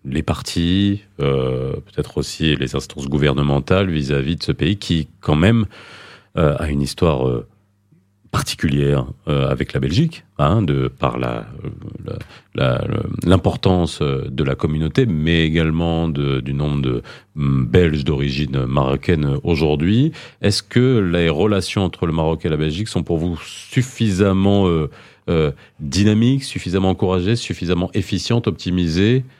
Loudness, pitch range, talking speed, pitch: -19 LUFS, 70-100 Hz, 135 wpm, 85 Hz